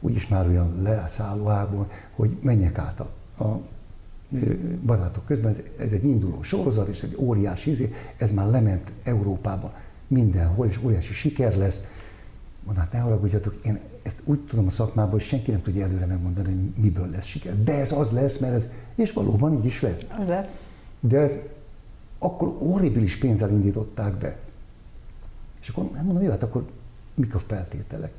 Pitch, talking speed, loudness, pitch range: 110 Hz, 165 wpm, -25 LUFS, 100-130 Hz